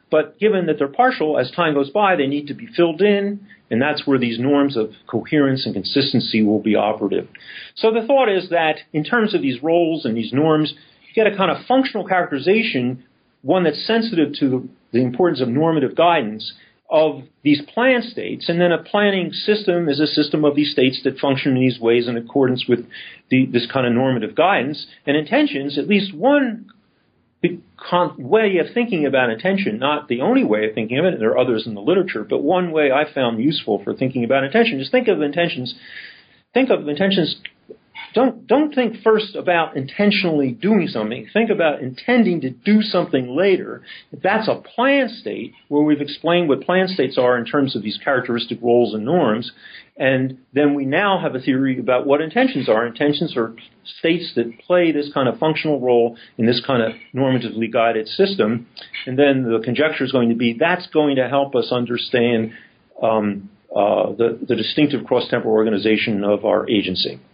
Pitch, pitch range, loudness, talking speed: 145 Hz, 125-185 Hz, -18 LUFS, 190 wpm